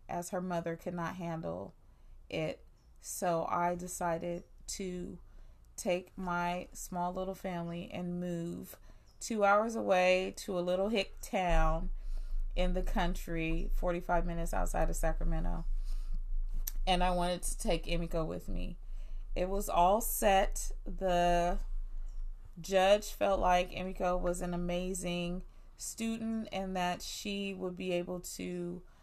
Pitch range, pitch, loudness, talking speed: 175-190 Hz, 180 Hz, -35 LUFS, 130 wpm